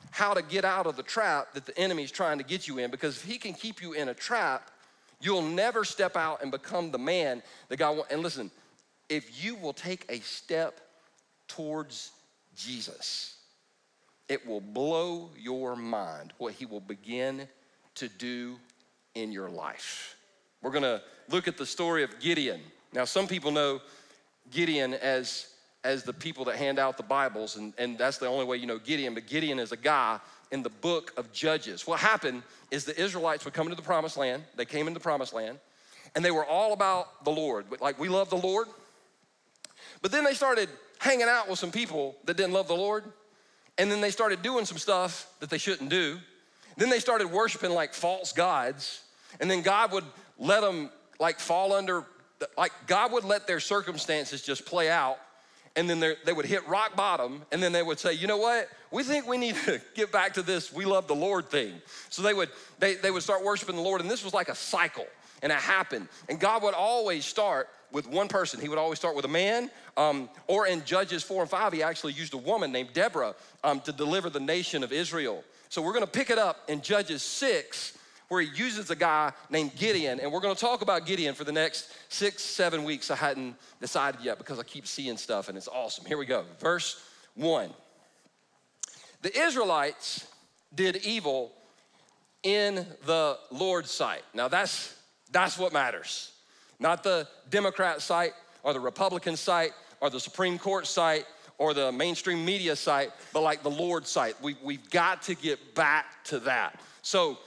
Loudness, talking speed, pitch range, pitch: -30 LUFS, 200 wpm, 145-195 Hz, 170 Hz